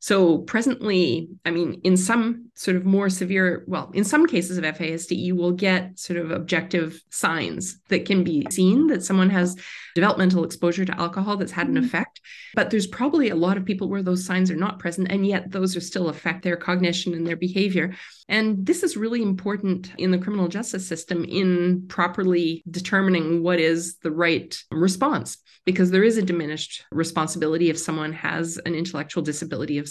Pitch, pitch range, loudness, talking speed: 180 Hz, 170-195 Hz, -23 LUFS, 185 wpm